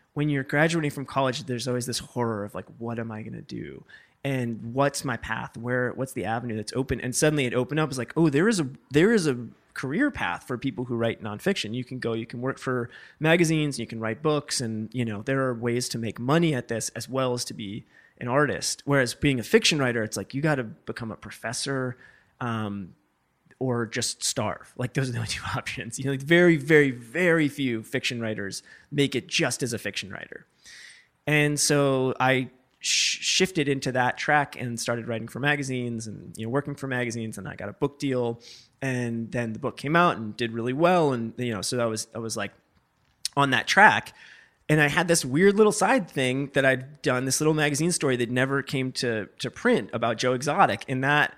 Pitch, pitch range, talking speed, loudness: 130 Hz, 115-145 Hz, 225 wpm, -25 LUFS